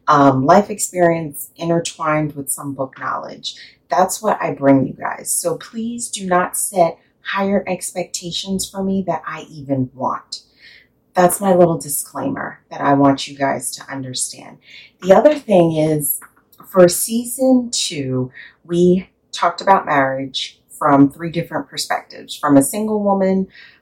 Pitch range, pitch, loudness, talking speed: 140-195 Hz, 170 Hz, -17 LUFS, 145 wpm